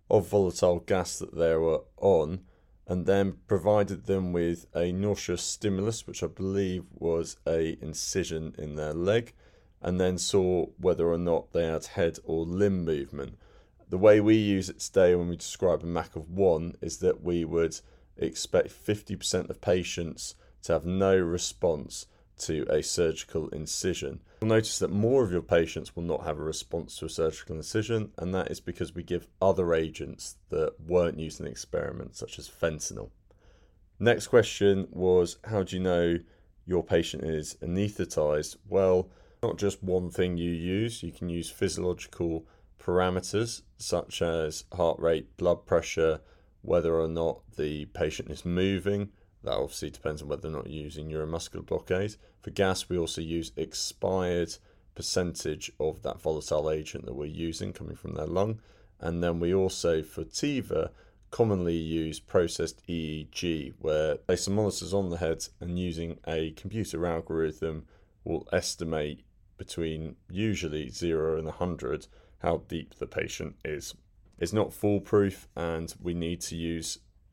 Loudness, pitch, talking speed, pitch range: -30 LUFS, 85 Hz, 160 wpm, 80-95 Hz